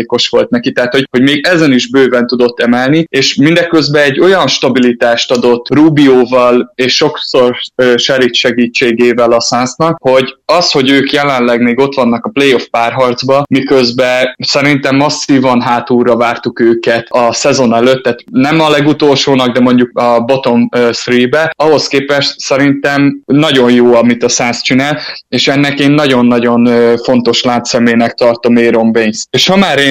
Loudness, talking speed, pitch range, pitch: -9 LUFS, 155 wpm, 120-140 Hz, 125 Hz